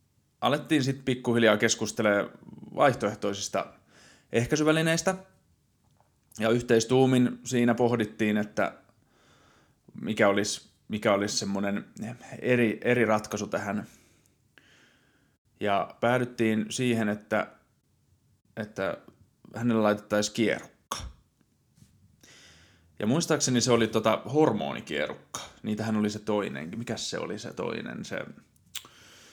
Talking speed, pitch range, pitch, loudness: 90 wpm, 105-125 Hz, 115 Hz, -27 LUFS